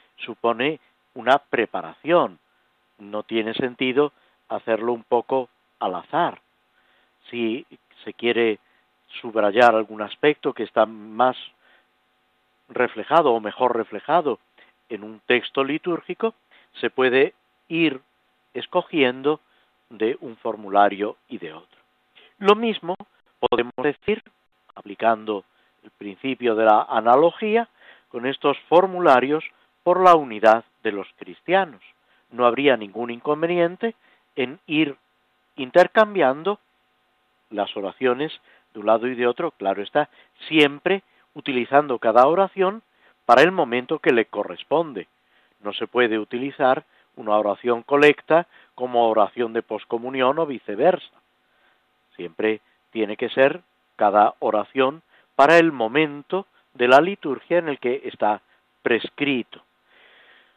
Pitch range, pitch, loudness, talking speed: 115-160 Hz, 130 Hz, -21 LUFS, 115 wpm